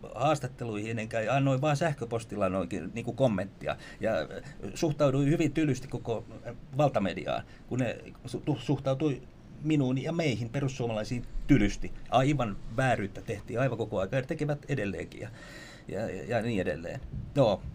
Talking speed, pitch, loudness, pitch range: 135 wpm, 130 Hz, -31 LUFS, 115-150 Hz